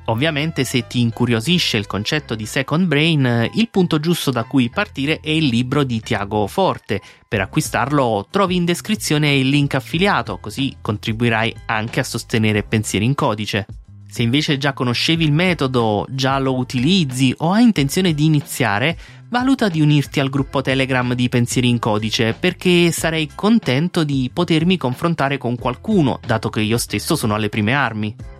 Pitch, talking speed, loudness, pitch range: 135 Hz, 165 wpm, -18 LUFS, 115-155 Hz